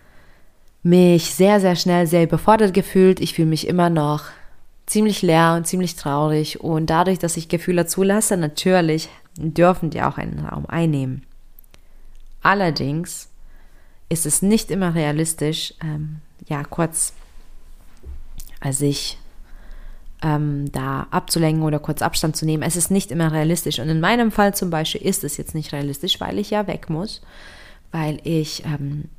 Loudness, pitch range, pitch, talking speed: -19 LUFS, 145-175 Hz, 160 Hz, 150 wpm